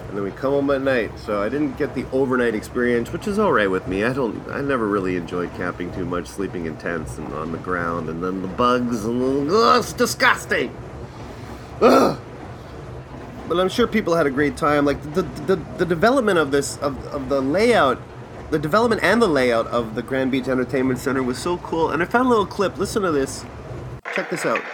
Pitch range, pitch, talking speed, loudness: 110-155 Hz, 130 Hz, 220 wpm, -21 LUFS